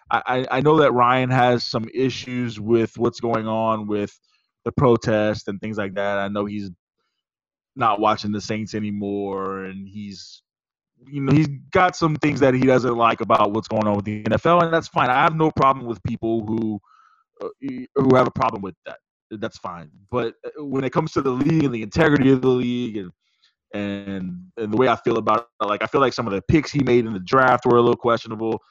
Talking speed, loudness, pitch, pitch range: 215 wpm, -20 LUFS, 120 Hz, 105-135 Hz